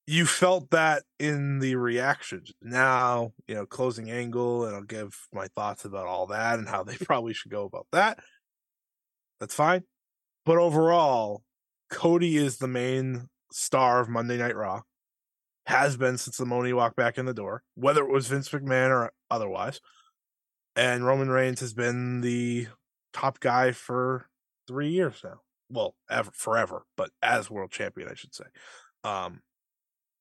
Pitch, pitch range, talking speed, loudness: 130 Hz, 120-140 Hz, 160 wpm, -27 LUFS